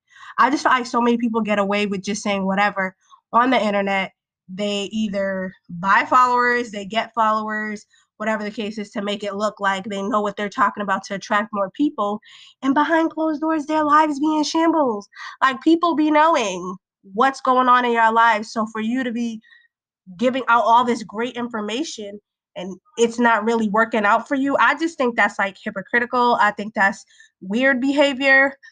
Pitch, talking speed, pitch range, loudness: 225 Hz, 190 wpm, 205-265 Hz, -19 LUFS